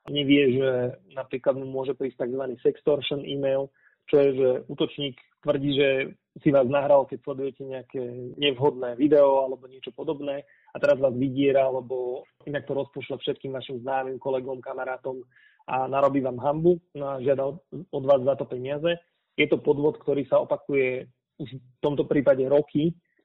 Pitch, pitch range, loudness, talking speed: 140 Hz, 130-145 Hz, -25 LUFS, 155 wpm